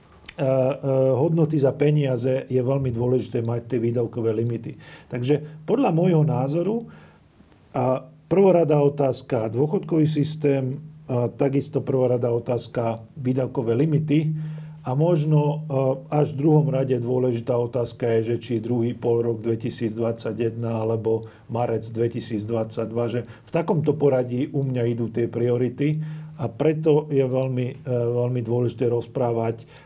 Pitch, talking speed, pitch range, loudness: 130 Hz, 115 wpm, 120-150 Hz, -23 LUFS